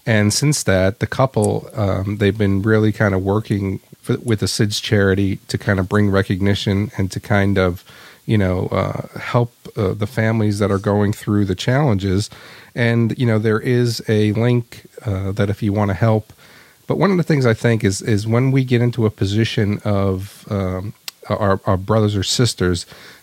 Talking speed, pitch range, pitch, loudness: 195 wpm, 100-120 Hz, 105 Hz, -18 LUFS